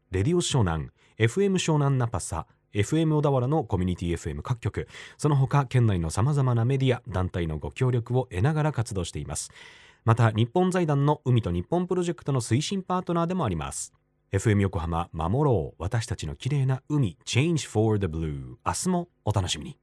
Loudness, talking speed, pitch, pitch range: -26 LUFS, 400 characters per minute, 120 Hz, 95-150 Hz